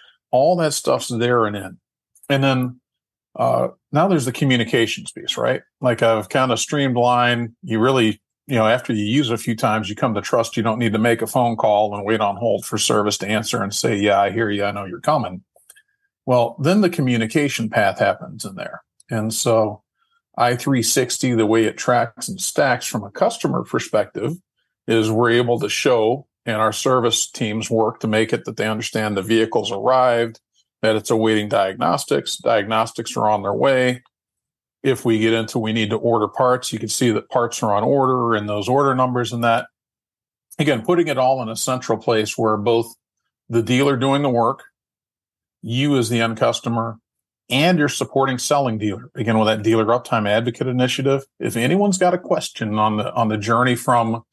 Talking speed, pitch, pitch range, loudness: 195 wpm, 115 Hz, 110-130 Hz, -19 LUFS